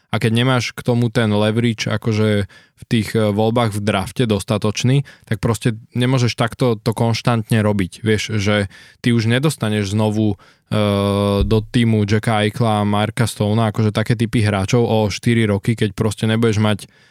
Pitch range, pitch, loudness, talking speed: 105-120 Hz, 110 Hz, -18 LUFS, 160 wpm